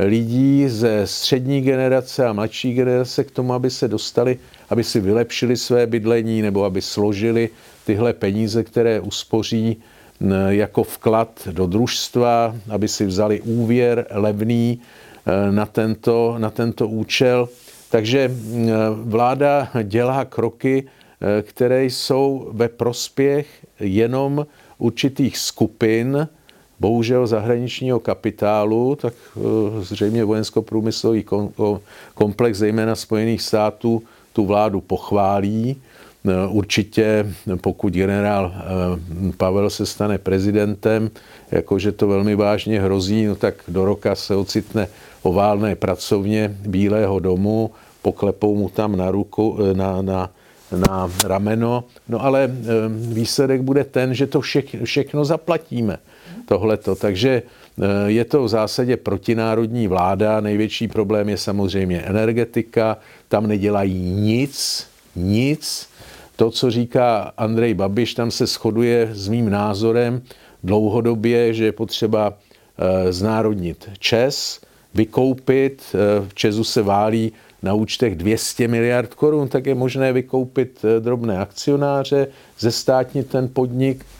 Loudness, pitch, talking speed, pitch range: -19 LUFS, 110 Hz, 110 wpm, 105-125 Hz